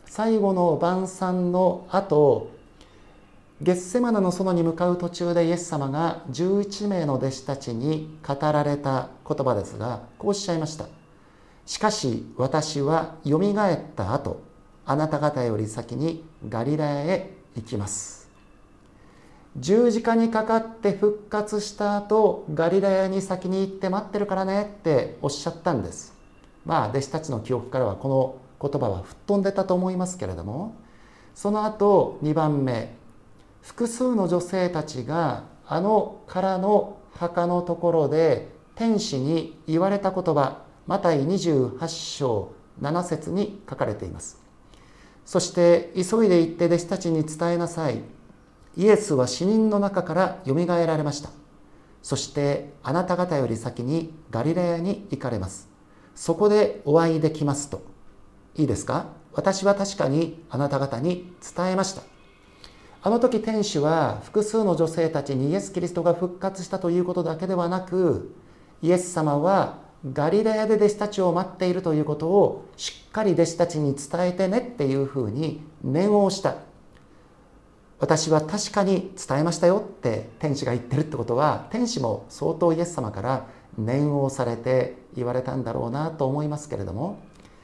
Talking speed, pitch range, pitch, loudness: 300 characters per minute, 135-185 Hz, 165 Hz, -24 LUFS